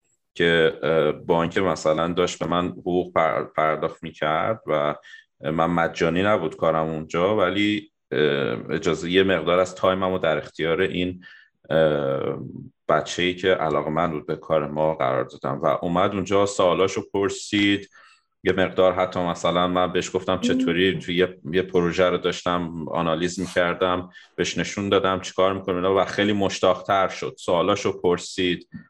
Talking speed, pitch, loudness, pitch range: 140 wpm, 90 Hz, -23 LUFS, 85-95 Hz